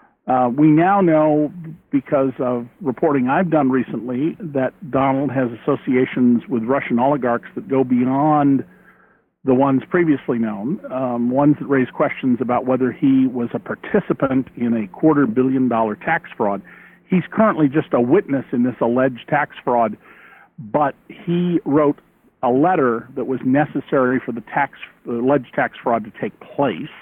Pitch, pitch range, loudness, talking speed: 135 Hz, 125-150 Hz, -19 LUFS, 155 wpm